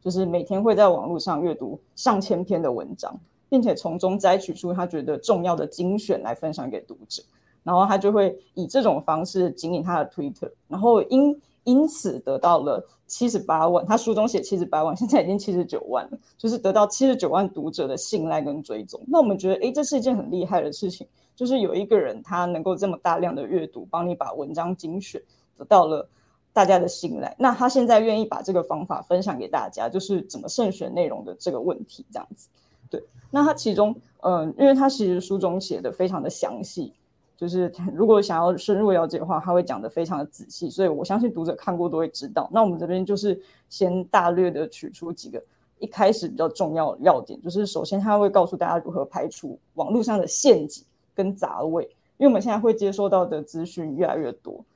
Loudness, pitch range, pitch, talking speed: -23 LUFS, 175-220 Hz, 190 Hz, 325 characters per minute